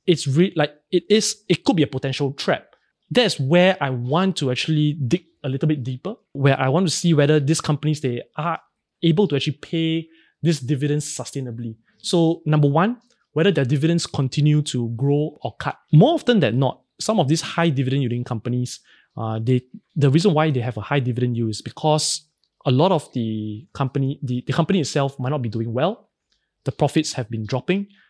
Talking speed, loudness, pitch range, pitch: 200 wpm, -21 LUFS, 130-170 Hz, 150 Hz